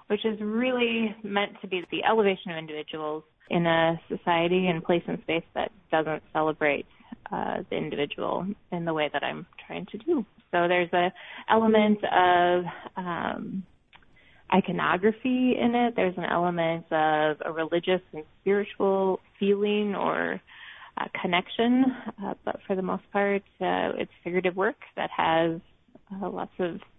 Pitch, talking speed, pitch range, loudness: 185 Hz, 150 wpm, 165-210 Hz, -27 LUFS